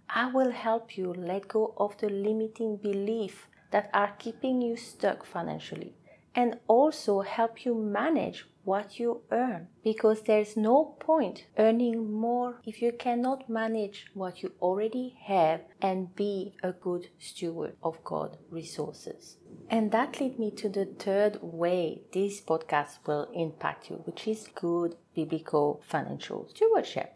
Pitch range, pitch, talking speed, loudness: 185-230 Hz, 210 Hz, 145 wpm, -30 LUFS